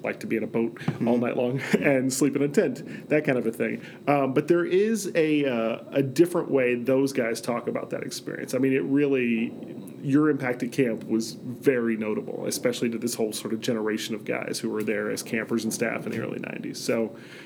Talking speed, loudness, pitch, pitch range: 225 wpm, -26 LUFS, 125 Hz, 115-140 Hz